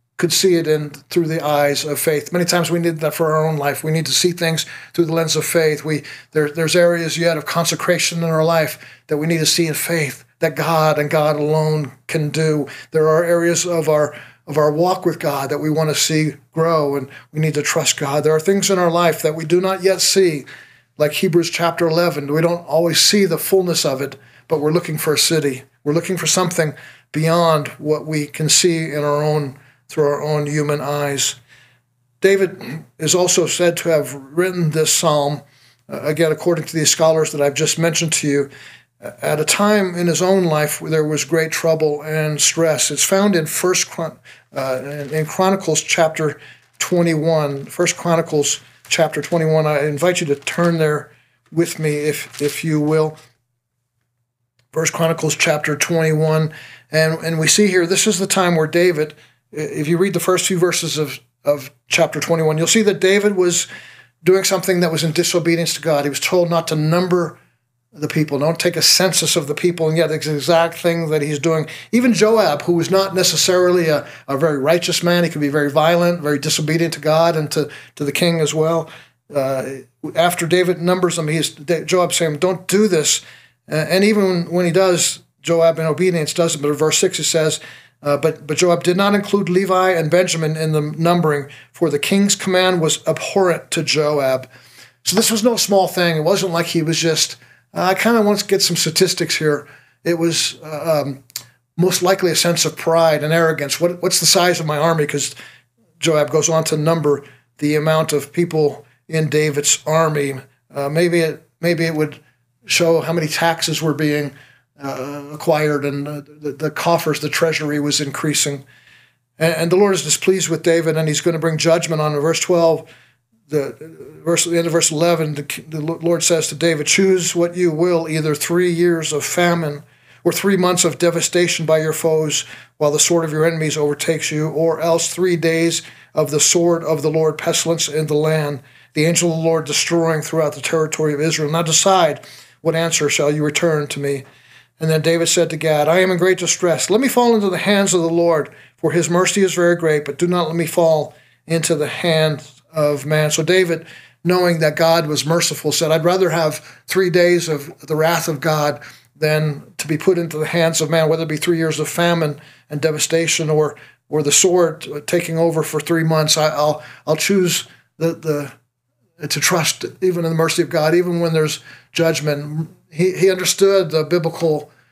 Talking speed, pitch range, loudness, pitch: 205 wpm, 150-170 Hz, -17 LUFS, 160 Hz